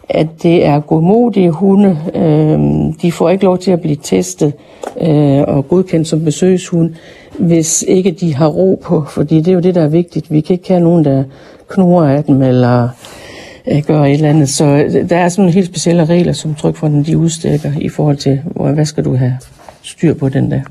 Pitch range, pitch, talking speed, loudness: 145-175 Hz, 160 Hz, 200 wpm, -12 LUFS